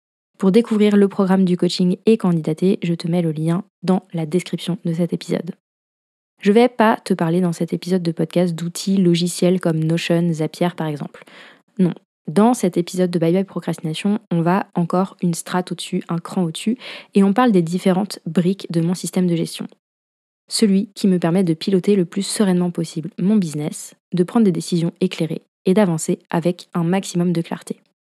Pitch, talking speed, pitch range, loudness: 180 Hz, 190 wpm, 170-195 Hz, -19 LUFS